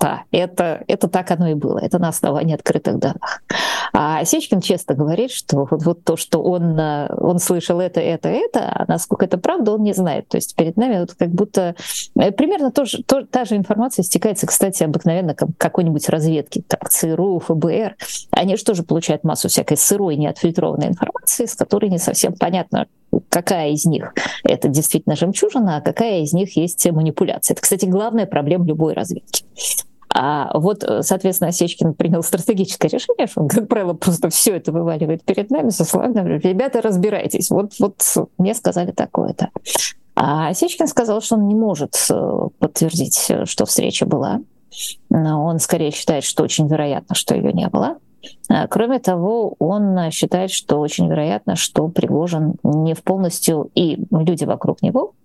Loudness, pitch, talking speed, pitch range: -18 LUFS, 180 Hz, 165 wpm, 160-210 Hz